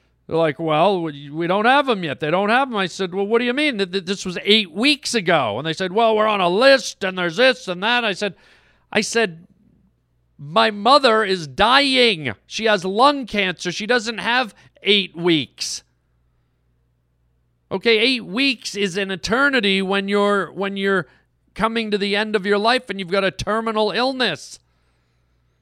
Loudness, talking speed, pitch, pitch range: -18 LUFS, 180 wpm, 200 Hz, 170-230 Hz